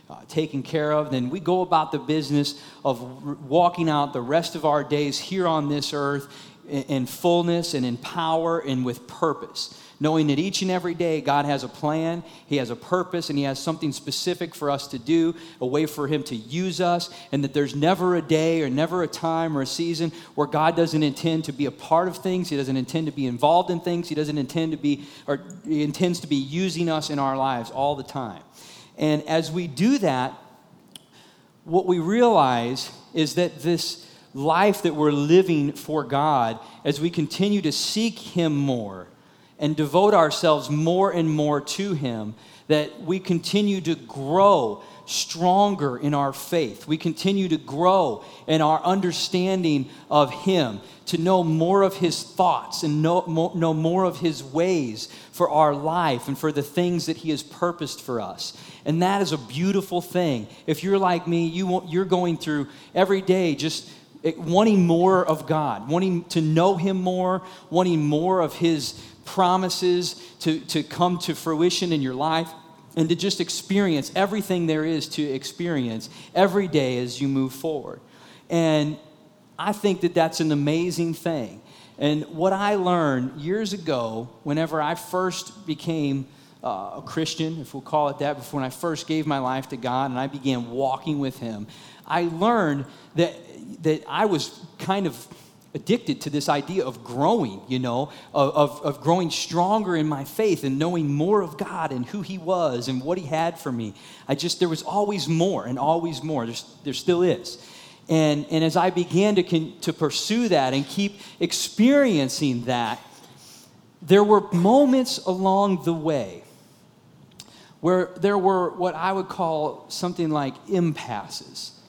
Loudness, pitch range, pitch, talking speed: -23 LUFS, 145-180 Hz, 160 Hz, 180 wpm